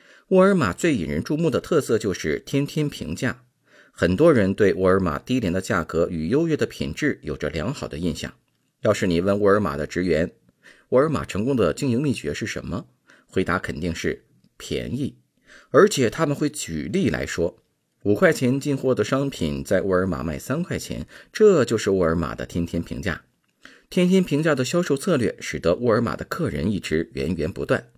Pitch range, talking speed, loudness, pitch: 85-145 Hz, 280 characters per minute, -23 LUFS, 105 Hz